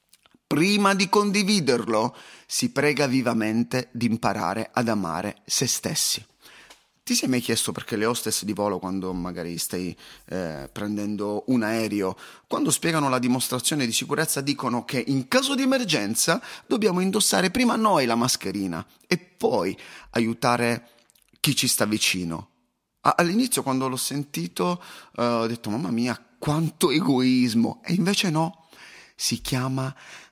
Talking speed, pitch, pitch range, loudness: 140 wpm, 120 Hz, 105-150 Hz, -24 LUFS